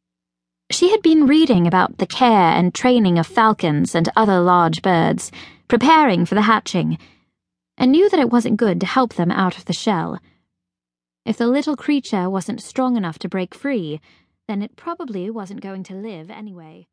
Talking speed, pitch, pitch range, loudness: 175 wpm, 200 Hz, 170-240 Hz, -17 LUFS